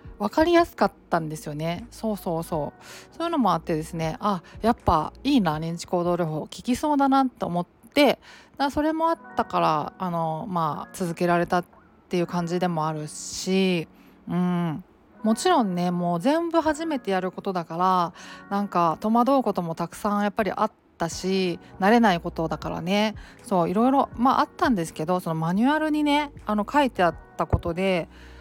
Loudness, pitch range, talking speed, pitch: -25 LUFS, 170-240 Hz, 360 characters per minute, 185 Hz